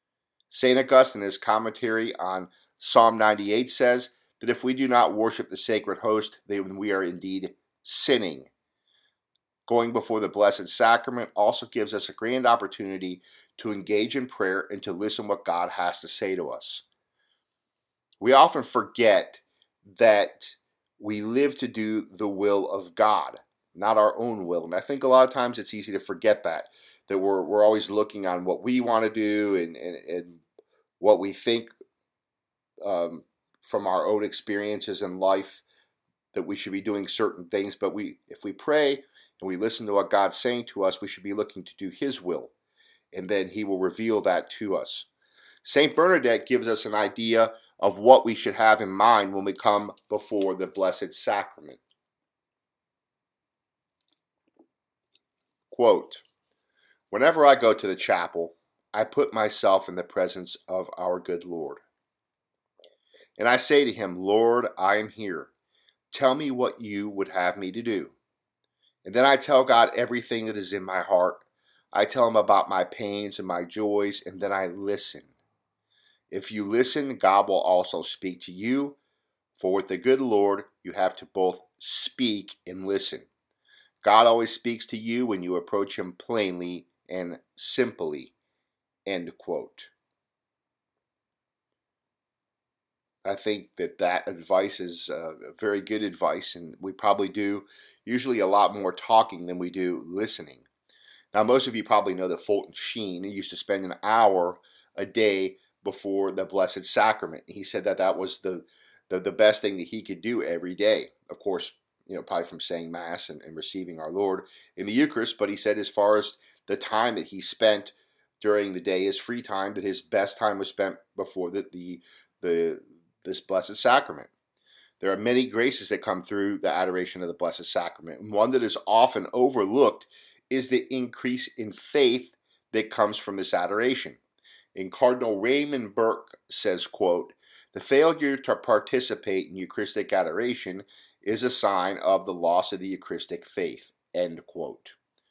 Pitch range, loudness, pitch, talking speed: 95-125 Hz, -25 LUFS, 105 Hz, 170 wpm